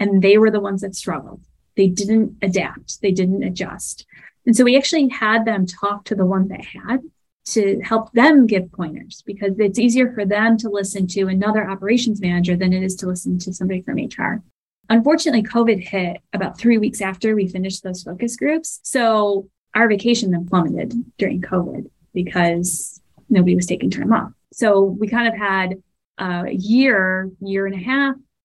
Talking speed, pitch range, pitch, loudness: 180 wpm, 185-225 Hz, 200 Hz, -18 LUFS